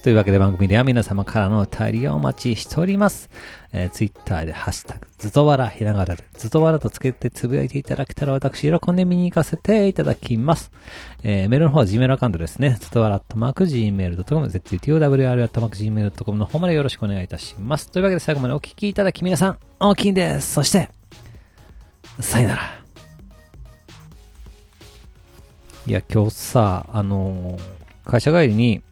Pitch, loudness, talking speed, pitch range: 115 Hz, -20 LUFS, 425 characters per minute, 95-150 Hz